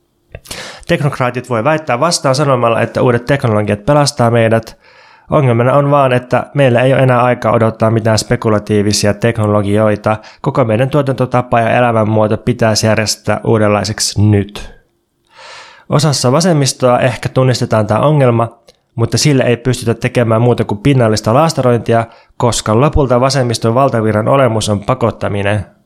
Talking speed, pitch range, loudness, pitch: 125 wpm, 110-135 Hz, -12 LUFS, 120 Hz